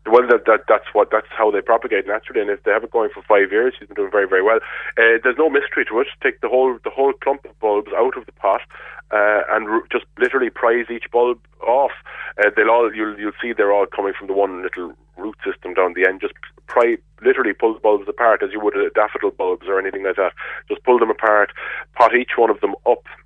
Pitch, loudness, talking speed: 395 Hz, -18 LUFS, 245 wpm